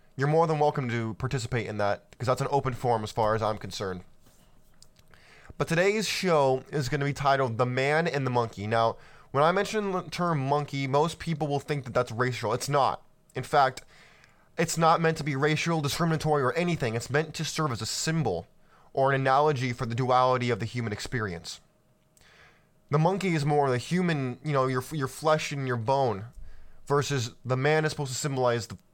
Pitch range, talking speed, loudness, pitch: 125-155 Hz, 200 wpm, -27 LUFS, 140 Hz